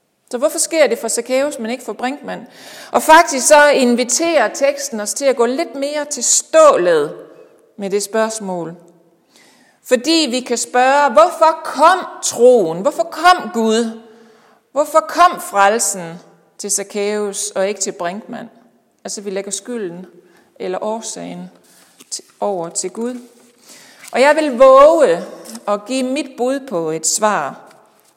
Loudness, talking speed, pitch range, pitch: -15 LUFS, 140 wpm, 210-295 Hz, 245 Hz